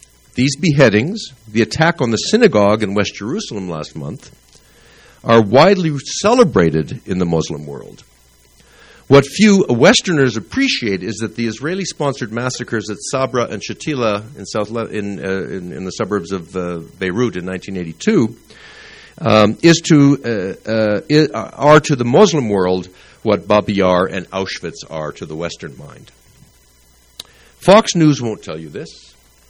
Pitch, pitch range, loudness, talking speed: 110 Hz, 95-140 Hz, -15 LUFS, 150 wpm